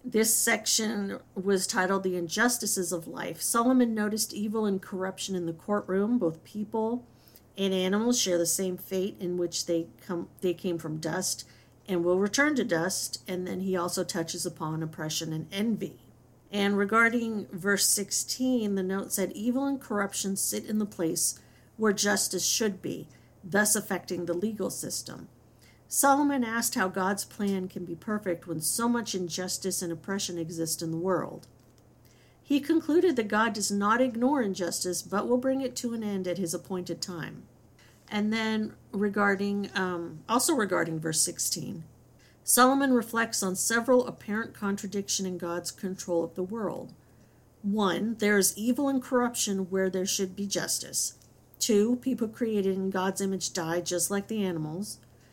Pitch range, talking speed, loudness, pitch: 175-220 Hz, 160 wpm, -28 LUFS, 195 Hz